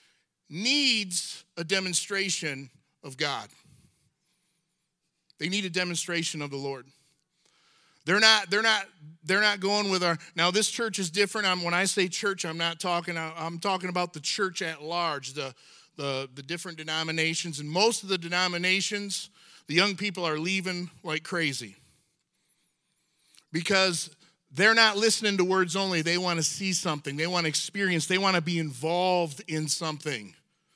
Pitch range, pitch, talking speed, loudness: 160-190 Hz, 175 Hz, 160 wpm, -26 LUFS